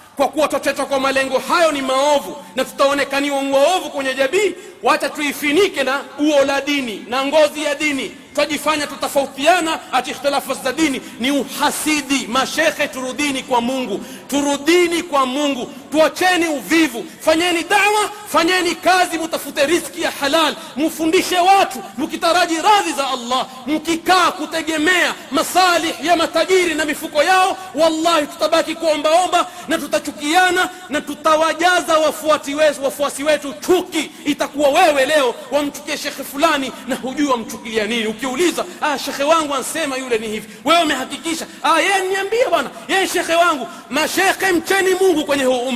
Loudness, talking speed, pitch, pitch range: -17 LUFS, 135 wpm, 300 Hz, 275-335 Hz